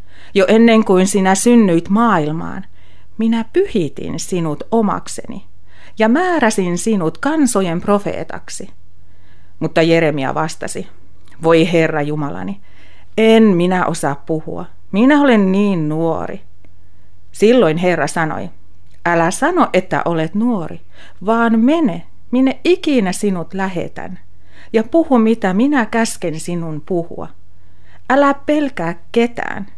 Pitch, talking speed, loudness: 175 Hz, 105 wpm, -15 LUFS